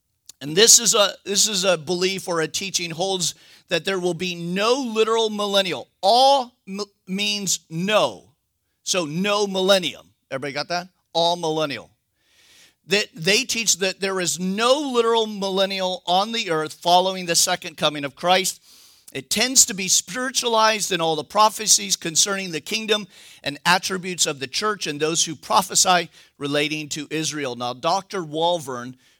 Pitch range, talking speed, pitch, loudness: 165-205 Hz, 160 wpm, 185 Hz, -20 LUFS